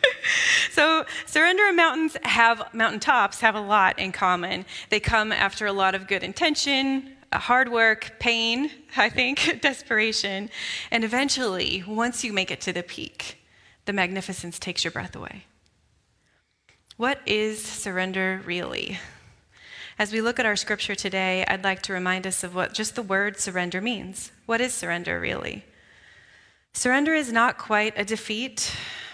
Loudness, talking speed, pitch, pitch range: -23 LUFS, 150 wpm, 220 Hz, 195-260 Hz